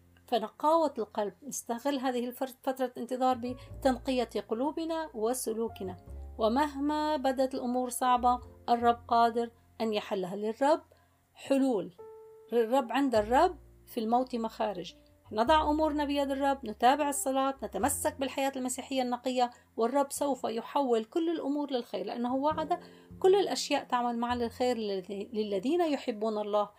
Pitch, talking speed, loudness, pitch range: 250 Hz, 120 wpm, -31 LUFS, 225-280 Hz